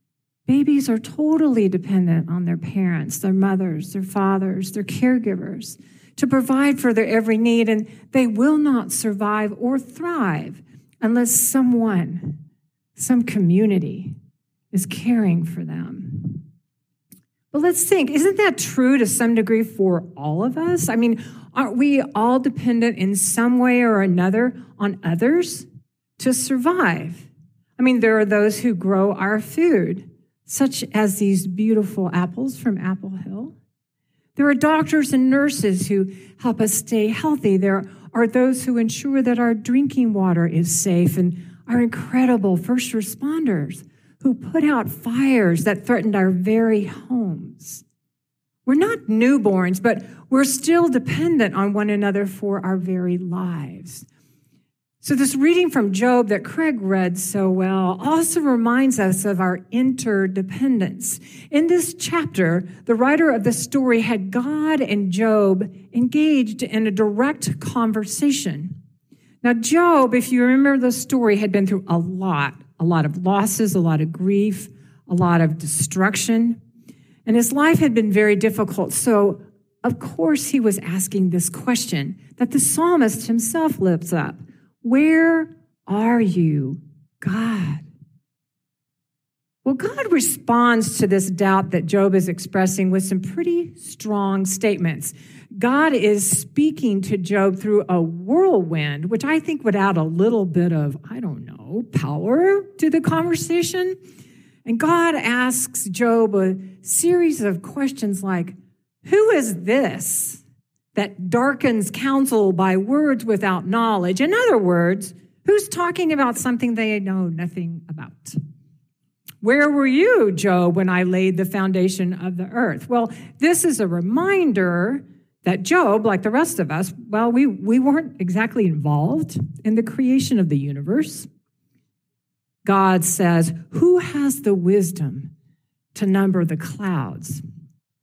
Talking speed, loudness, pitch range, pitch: 140 wpm, -19 LUFS, 185-255 Hz, 210 Hz